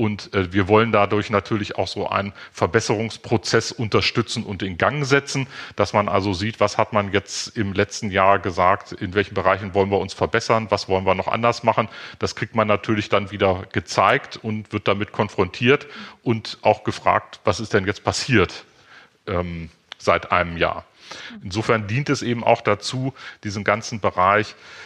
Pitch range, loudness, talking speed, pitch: 100-115 Hz, -21 LUFS, 170 wpm, 105 Hz